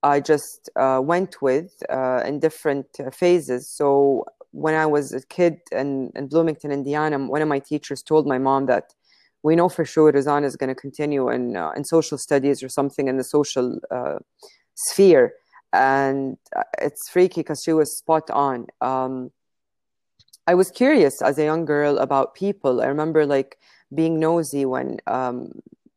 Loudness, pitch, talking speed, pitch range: -21 LUFS, 145 Hz, 170 wpm, 135-160 Hz